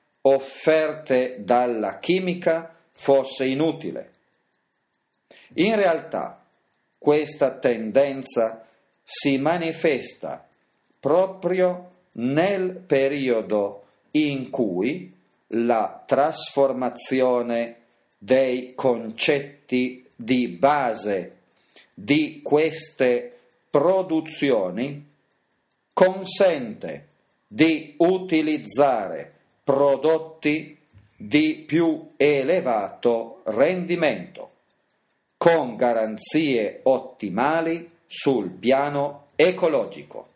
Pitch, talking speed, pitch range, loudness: 145 Hz, 60 wpm, 125-165 Hz, -23 LUFS